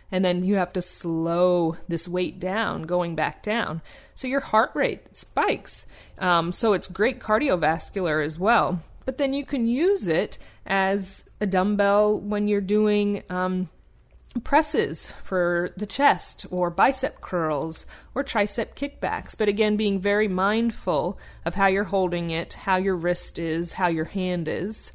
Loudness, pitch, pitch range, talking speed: -24 LUFS, 190 Hz, 175-210 Hz, 155 wpm